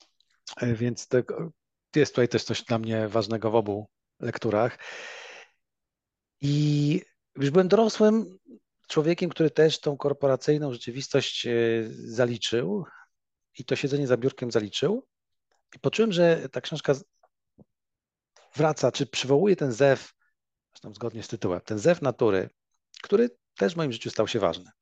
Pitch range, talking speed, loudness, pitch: 115-155 Hz, 130 wpm, -26 LUFS, 135 Hz